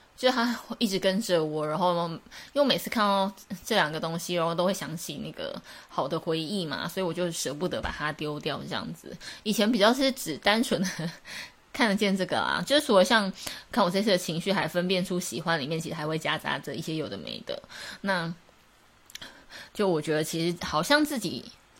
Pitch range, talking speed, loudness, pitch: 165-210 Hz, 295 characters per minute, -28 LUFS, 185 Hz